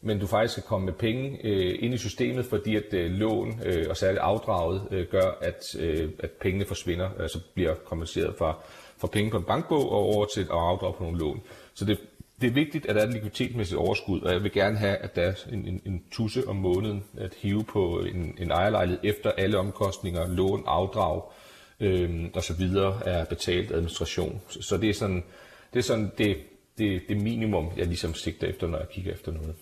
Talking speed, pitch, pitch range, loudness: 215 wpm, 100 Hz, 90-105 Hz, -28 LUFS